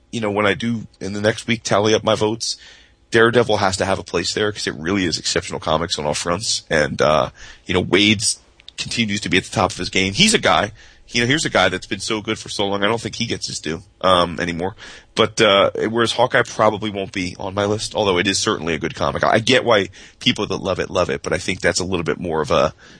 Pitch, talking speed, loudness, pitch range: 105 Hz, 270 wpm, -19 LUFS, 95-110 Hz